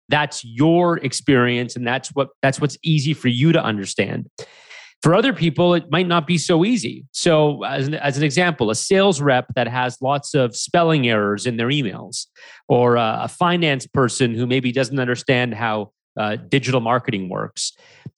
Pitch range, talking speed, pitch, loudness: 125-160 Hz, 175 wpm, 135 Hz, -19 LUFS